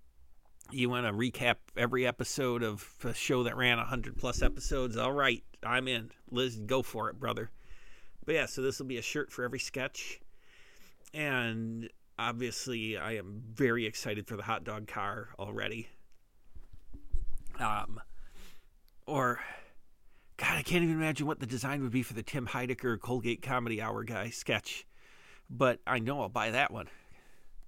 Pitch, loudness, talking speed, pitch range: 120 Hz, -34 LUFS, 160 wpm, 110-130 Hz